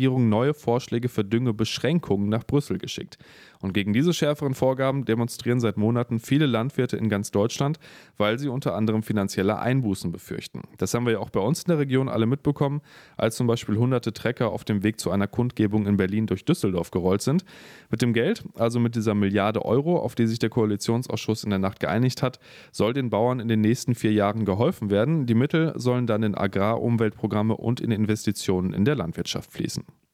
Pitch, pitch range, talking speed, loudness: 115 Hz, 105-130 Hz, 195 wpm, -24 LUFS